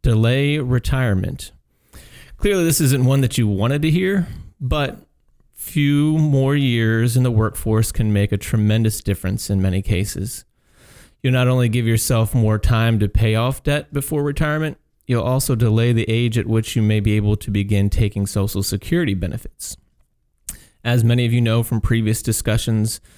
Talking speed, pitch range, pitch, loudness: 165 wpm, 105-130 Hz, 115 Hz, -19 LUFS